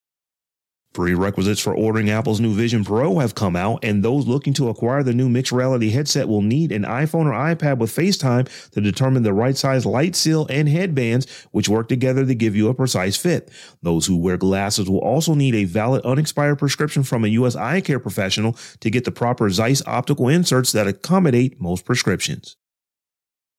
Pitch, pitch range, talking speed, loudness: 125 Hz, 105-140 Hz, 190 wpm, -19 LUFS